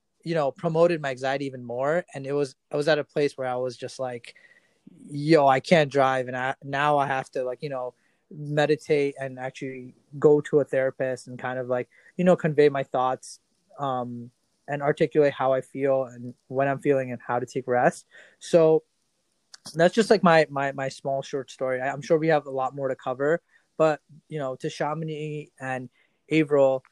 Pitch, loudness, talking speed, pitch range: 140 Hz, -25 LUFS, 205 wpm, 130-150 Hz